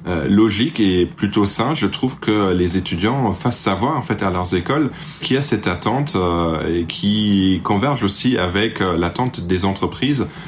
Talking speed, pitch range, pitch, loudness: 165 wpm, 90-120 Hz, 100 Hz, -18 LUFS